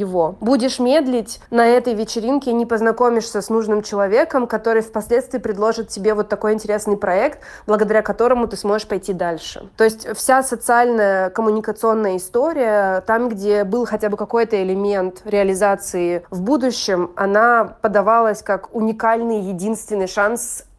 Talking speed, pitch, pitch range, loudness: 135 wpm, 215 Hz, 205-235 Hz, -18 LUFS